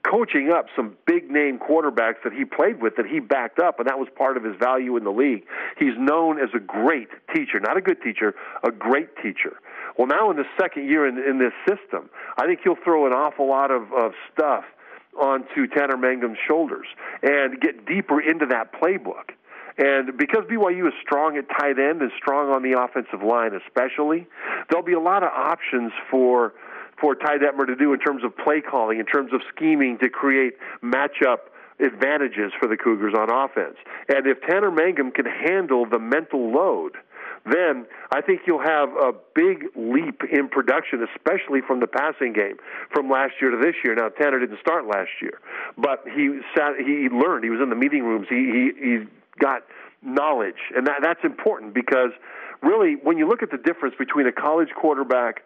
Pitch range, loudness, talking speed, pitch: 130-195 Hz, -22 LUFS, 195 wpm, 145 Hz